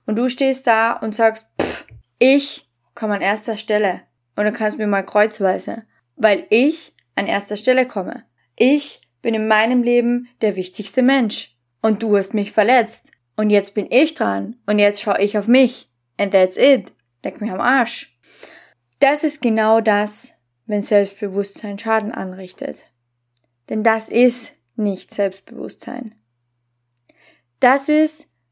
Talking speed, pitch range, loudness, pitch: 145 wpm, 195-245 Hz, -18 LUFS, 215 Hz